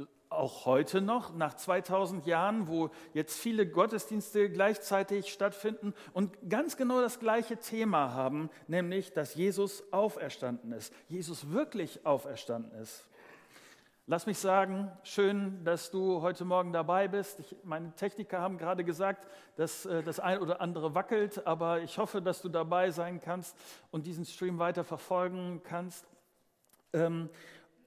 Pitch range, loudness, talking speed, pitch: 165-200 Hz, -34 LUFS, 140 wpm, 180 Hz